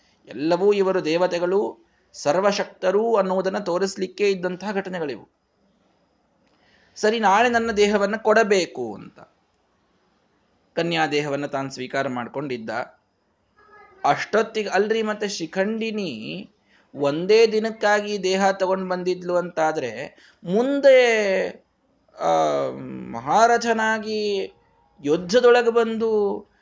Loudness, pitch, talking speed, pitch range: -21 LUFS, 195 Hz, 75 wpm, 175-220 Hz